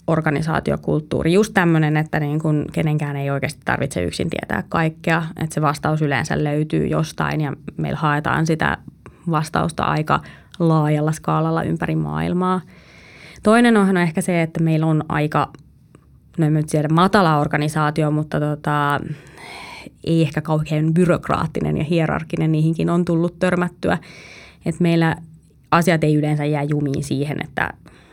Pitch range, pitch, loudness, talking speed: 150-165 Hz, 155 Hz, -19 LUFS, 140 wpm